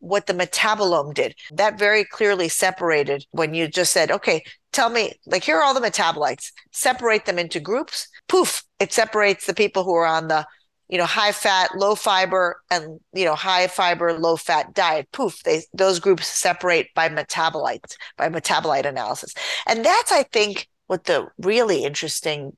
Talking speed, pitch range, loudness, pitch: 175 wpm, 165-210 Hz, -20 LUFS, 185 Hz